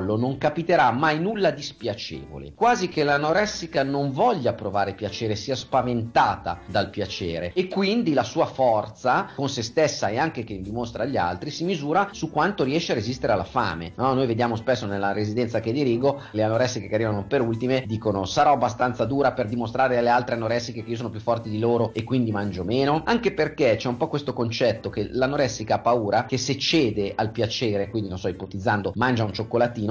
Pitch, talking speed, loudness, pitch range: 120 Hz, 195 wpm, -24 LUFS, 105-140 Hz